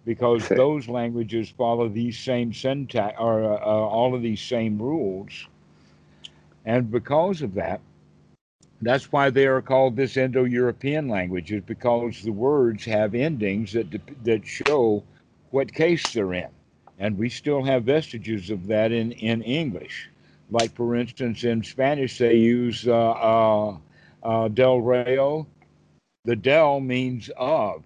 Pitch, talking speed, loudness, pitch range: 120 Hz, 140 wpm, -23 LUFS, 110-130 Hz